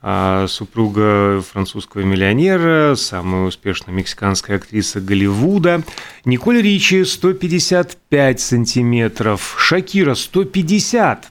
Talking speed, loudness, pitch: 75 wpm, -15 LUFS, 120 Hz